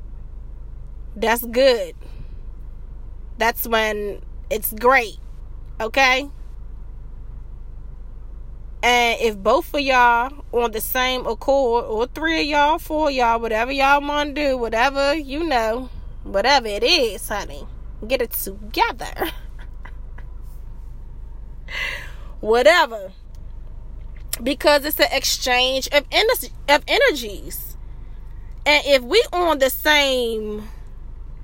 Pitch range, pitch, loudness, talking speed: 235-300 Hz, 270 Hz, -19 LUFS, 105 wpm